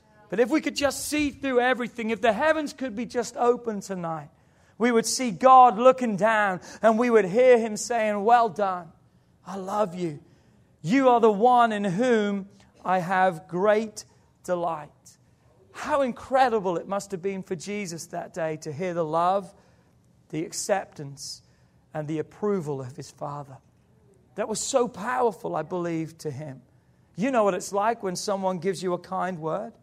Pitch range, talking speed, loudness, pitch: 175-240 Hz, 170 wpm, -24 LUFS, 200 Hz